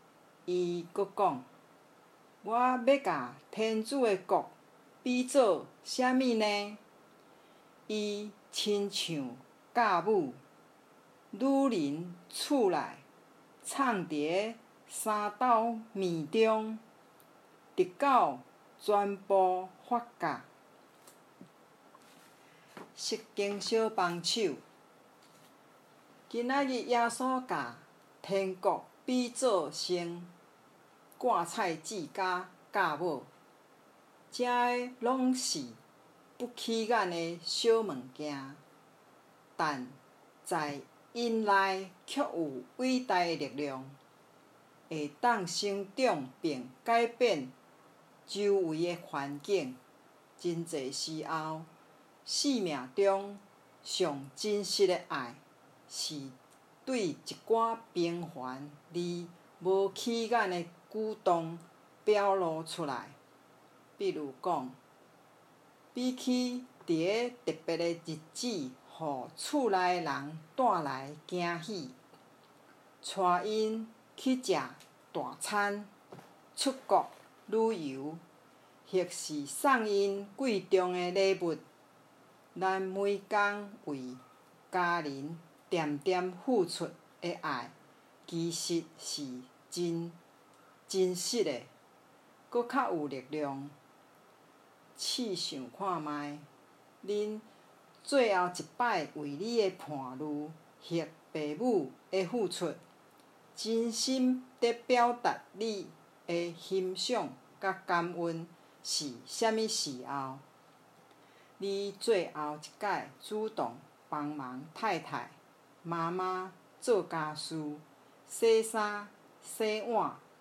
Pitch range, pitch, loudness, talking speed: 160-225 Hz, 190 Hz, -33 LUFS, 120 characters per minute